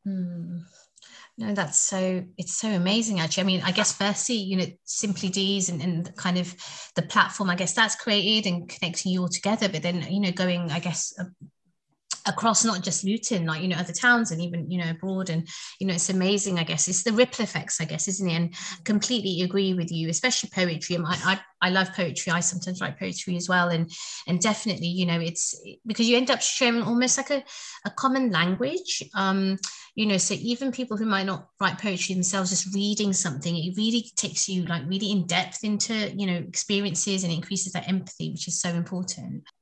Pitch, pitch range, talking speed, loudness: 185 Hz, 175-205 Hz, 210 wpm, -25 LUFS